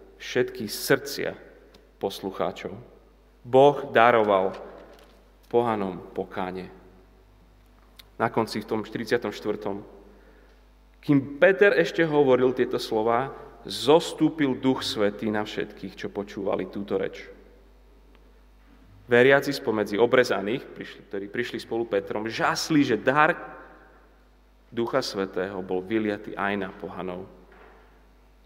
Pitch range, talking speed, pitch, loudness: 95-130 Hz, 95 wpm, 105 Hz, -25 LUFS